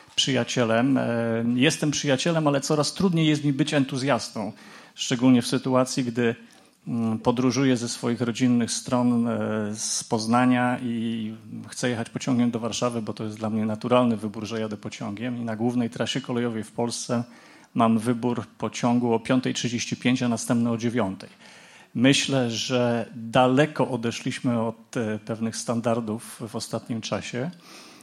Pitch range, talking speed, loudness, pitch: 115-130 Hz, 135 wpm, -25 LUFS, 120 Hz